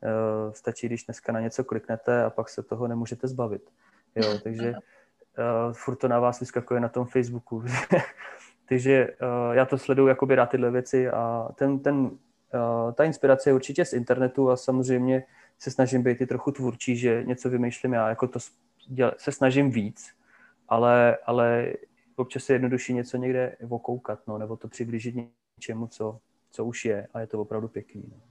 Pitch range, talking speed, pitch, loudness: 115-130 Hz, 170 wpm, 120 Hz, -26 LUFS